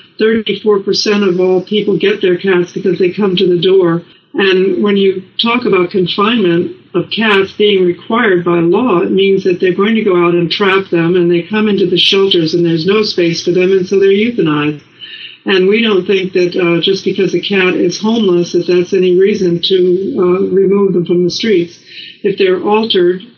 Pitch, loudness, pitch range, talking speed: 190 Hz, -11 LUFS, 175-200 Hz, 205 wpm